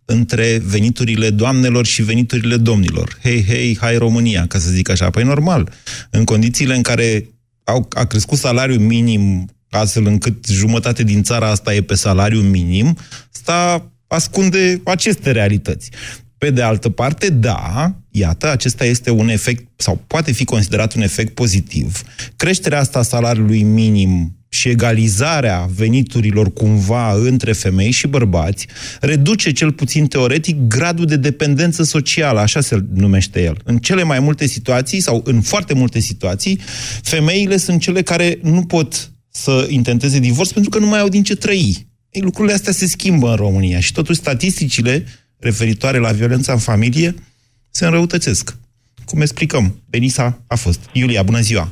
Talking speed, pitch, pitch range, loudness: 155 wpm, 120 Hz, 110-145 Hz, -15 LUFS